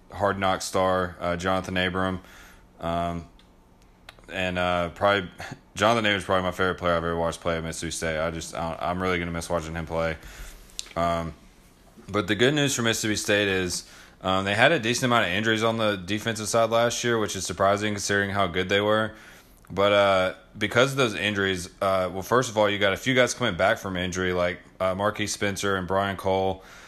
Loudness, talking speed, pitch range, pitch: -25 LUFS, 210 wpm, 90-105 Hz, 95 Hz